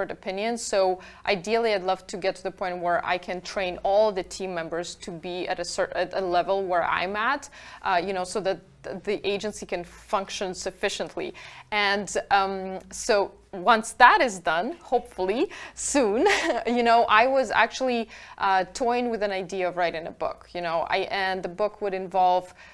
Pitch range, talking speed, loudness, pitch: 185-215 Hz, 185 wpm, -25 LUFS, 195 Hz